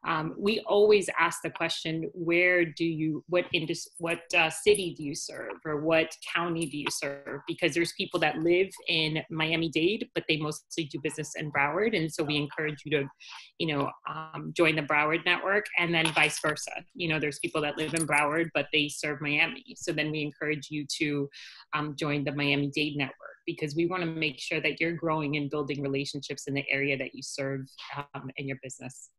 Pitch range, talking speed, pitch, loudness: 145-165 Hz, 205 wpm, 155 Hz, -29 LUFS